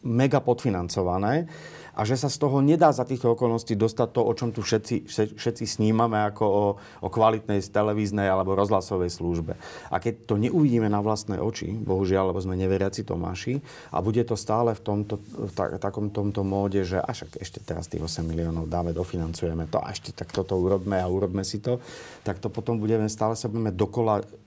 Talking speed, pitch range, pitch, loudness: 190 wpm, 95-115 Hz, 105 Hz, -26 LUFS